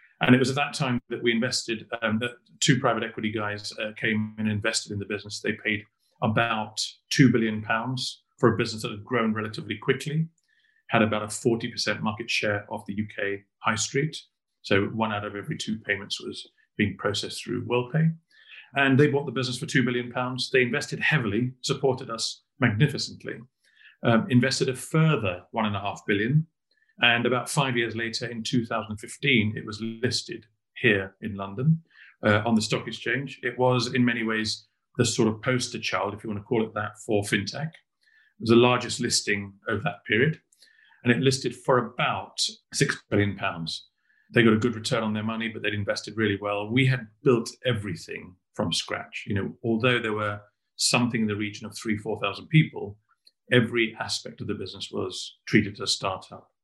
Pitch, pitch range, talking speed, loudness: 115 Hz, 105-125 Hz, 185 wpm, -26 LUFS